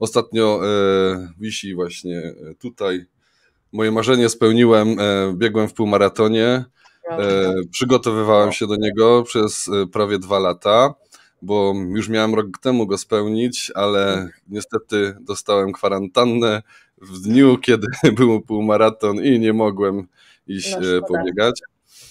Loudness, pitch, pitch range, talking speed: -18 LUFS, 105 Hz, 95-115 Hz, 115 wpm